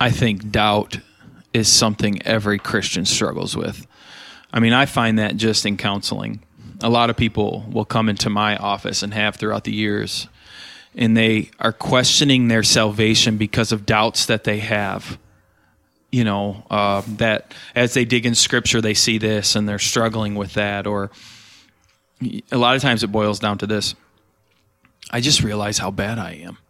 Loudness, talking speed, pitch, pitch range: -18 LUFS, 175 wpm, 110 Hz, 105-115 Hz